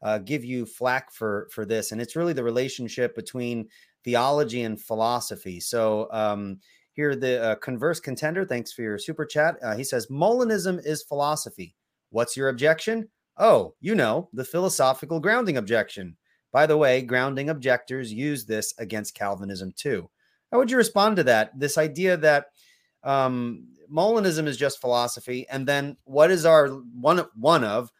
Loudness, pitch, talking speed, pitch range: -24 LUFS, 130 Hz, 165 wpm, 115-155 Hz